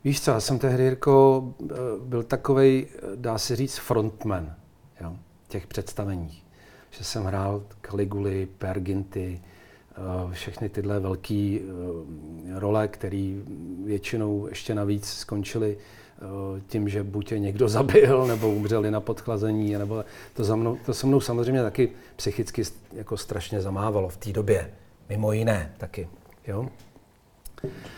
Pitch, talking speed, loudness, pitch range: 105 Hz, 125 wpm, -26 LUFS, 100-115 Hz